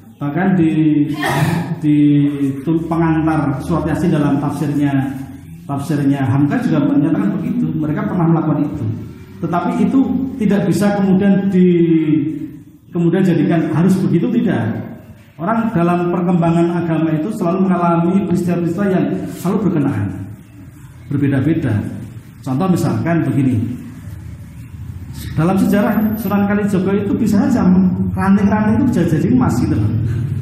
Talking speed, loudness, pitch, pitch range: 110 wpm, -16 LUFS, 160 Hz, 140-185 Hz